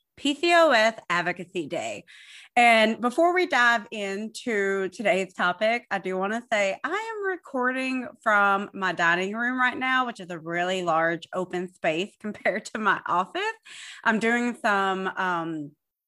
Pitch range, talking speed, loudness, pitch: 185-255 Hz, 145 wpm, -24 LUFS, 215 Hz